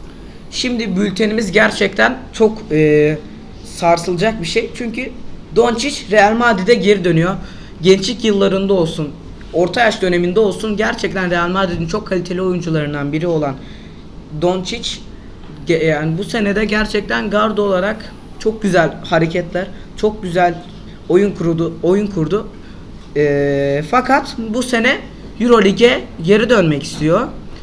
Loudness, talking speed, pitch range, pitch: -15 LUFS, 115 wpm, 170-220 Hz, 195 Hz